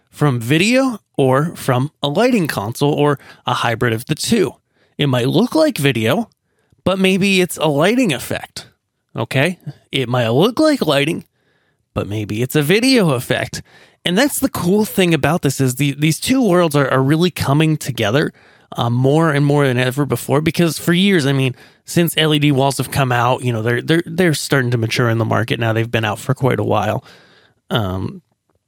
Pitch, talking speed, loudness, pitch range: 140 Hz, 190 wpm, -16 LUFS, 120-170 Hz